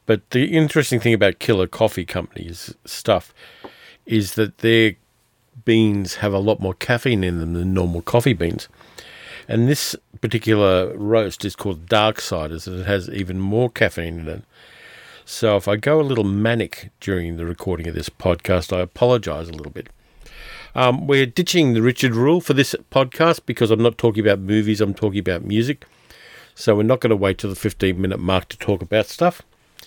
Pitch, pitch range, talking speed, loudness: 110 Hz, 95-120 Hz, 185 wpm, -19 LUFS